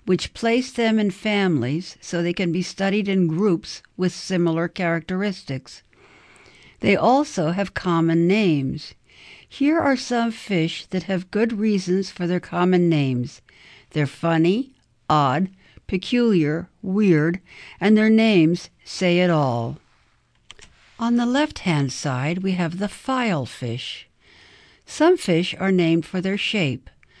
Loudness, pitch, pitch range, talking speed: -21 LUFS, 185 Hz, 165-205 Hz, 130 wpm